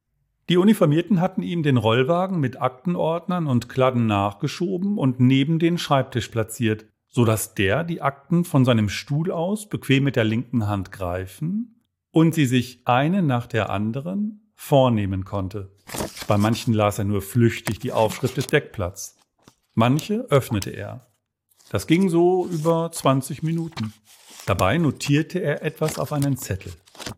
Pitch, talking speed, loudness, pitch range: 135 Hz, 145 wpm, -22 LUFS, 110-165 Hz